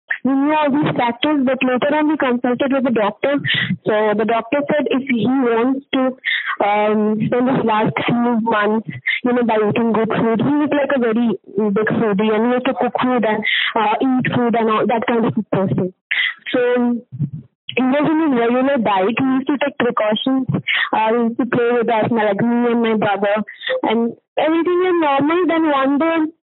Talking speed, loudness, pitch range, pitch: 195 wpm, -17 LUFS, 220-275 Hz, 240 Hz